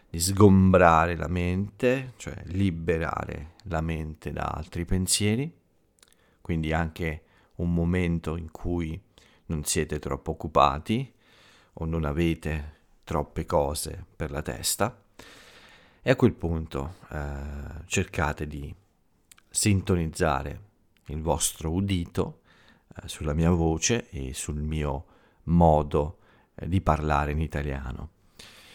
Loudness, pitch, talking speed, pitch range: -27 LUFS, 85 Hz, 110 wpm, 75-95 Hz